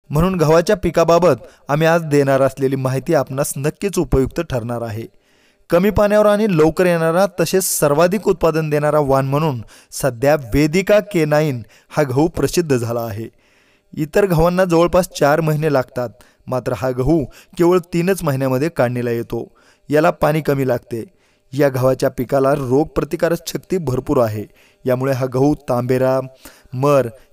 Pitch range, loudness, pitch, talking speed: 130-170 Hz, -17 LUFS, 145 Hz, 135 wpm